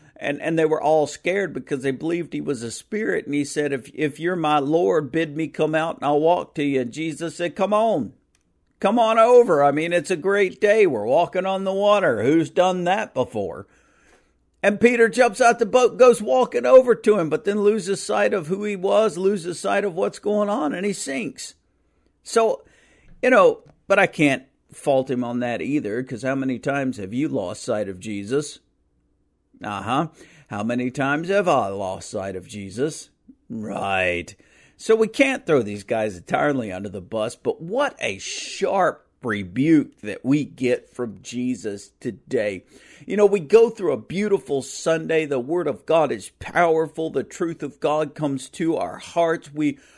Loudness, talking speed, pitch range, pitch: -21 LUFS, 190 wpm, 130-200 Hz, 160 Hz